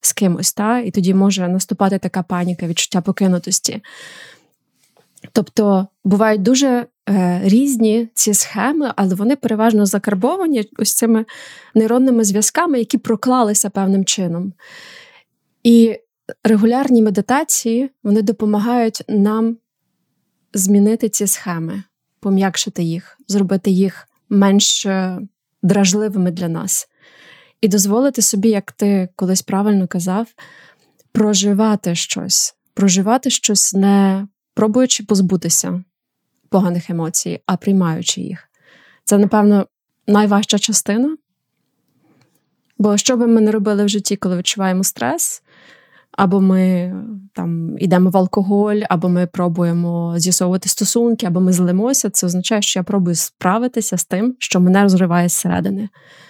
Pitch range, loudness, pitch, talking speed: 185-225 Hz, -16 LUFS, 205 Hz, 115 wpm